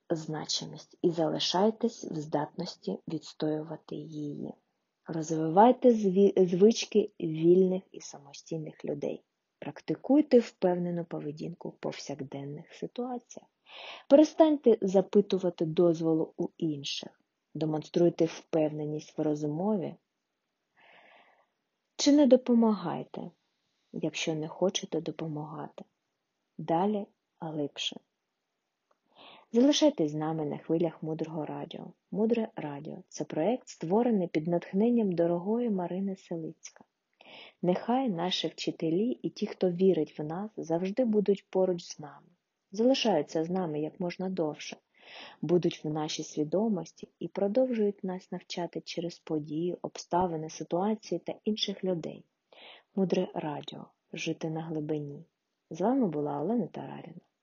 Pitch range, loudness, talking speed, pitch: 160-205 Hz, -30 LUFS, 105 wpm, 175 Hz